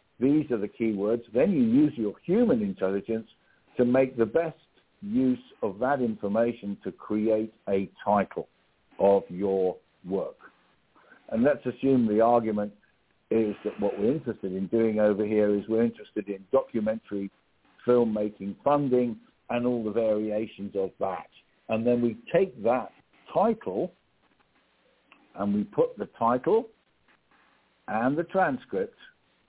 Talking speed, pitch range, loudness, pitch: 135 wpm, 105-130 Hz, -27 LUFS, 115 Hz